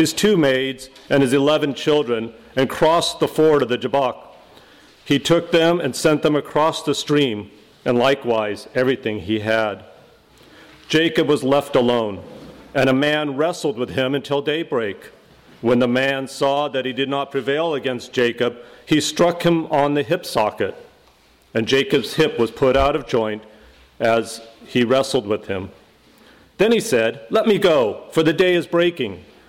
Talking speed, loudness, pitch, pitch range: 165 wpm, -19 LUFS, 135 Hz, 120-155 Hz